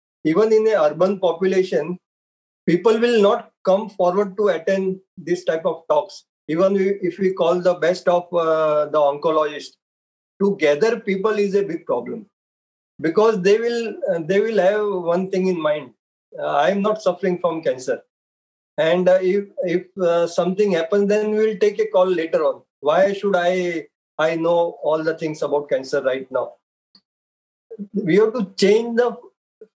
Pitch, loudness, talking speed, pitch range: 185 Hz, -20 LUFS, 165 wpm, 170-210 Hz